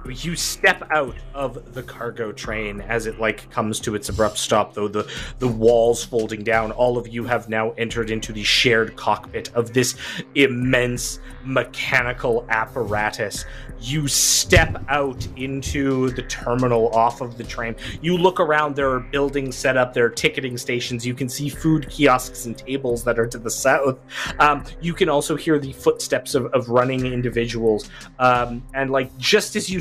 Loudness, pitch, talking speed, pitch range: -21 LUFS, 125 Hz, 175 wpm, 115-135 Hz